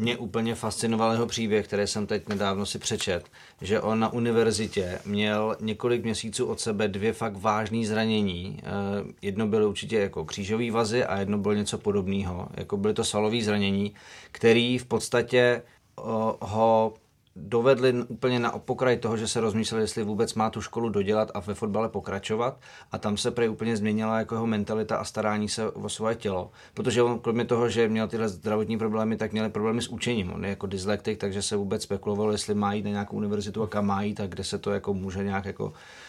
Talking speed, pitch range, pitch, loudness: 195 wpm, 105-115 Hz, 110 Hz, -27 LUFS